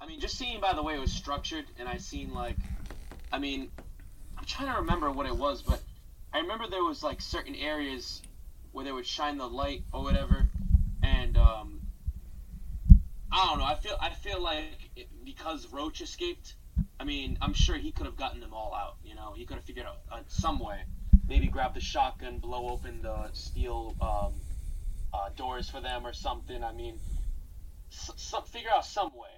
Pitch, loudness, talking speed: 95 Hz, -33 LUFS, 200 wpm